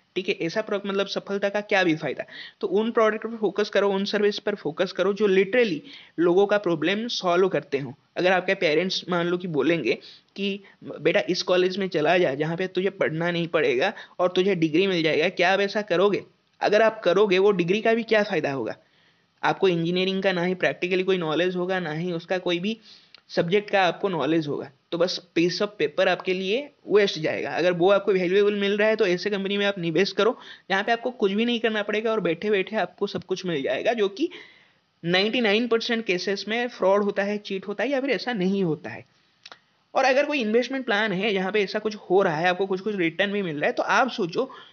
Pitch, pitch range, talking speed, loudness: 195 Hz, 180-210 Hz, 225 wpm, -24 LUFS